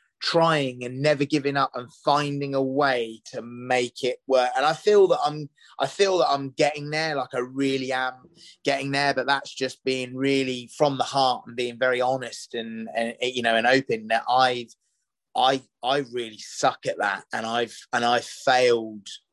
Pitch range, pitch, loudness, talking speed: 120-140 Hz, 130 Hz, -24 LUFS, 190 wpm